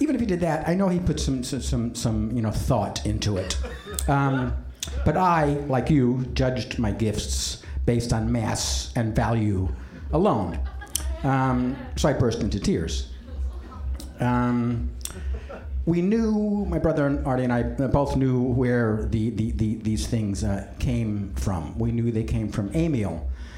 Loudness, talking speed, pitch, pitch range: -25 LUFS, 165 wpm, 115 Hz, 80-130 Hz